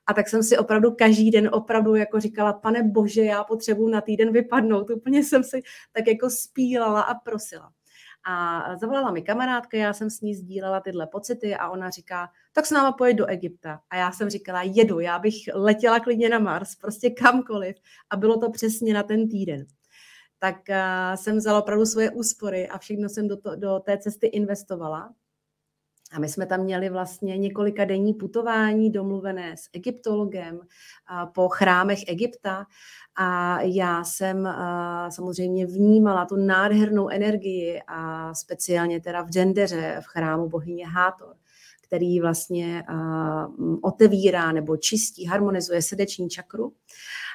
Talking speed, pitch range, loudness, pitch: 150 wpm, 180-220 Hz, -23 LUFS, 200 Hz